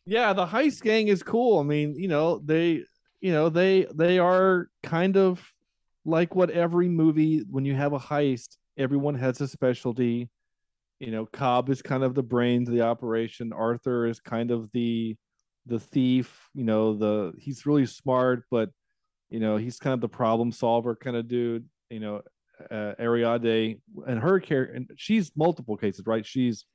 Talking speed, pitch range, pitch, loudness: 180 wpm, 115-165 Hz, 130 Hz, -26 LUFS